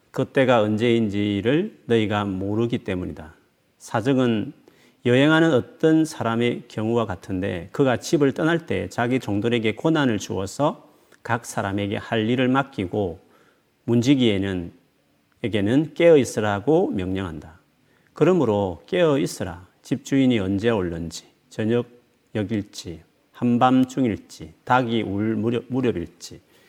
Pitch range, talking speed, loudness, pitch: 100-125 Hz, 270 characters per minute, -22 LUFS, 115 Hz